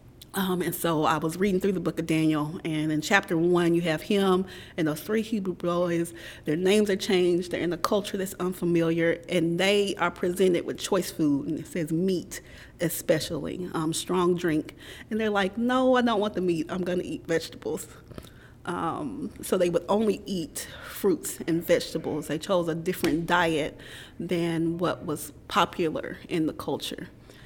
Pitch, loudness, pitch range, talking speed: 175 Hz, -27 LUFS, 160-190 Hz, 180 wpm